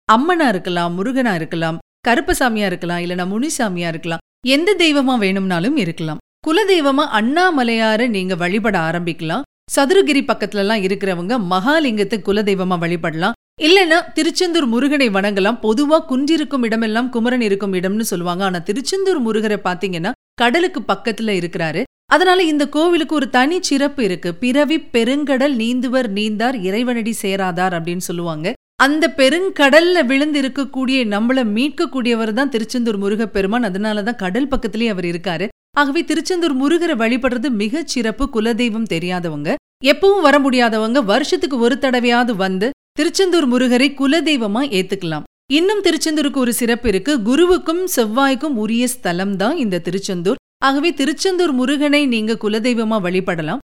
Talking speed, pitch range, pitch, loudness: 125 wpm, 200-290 Hz, 245 Hz, -17 LUFS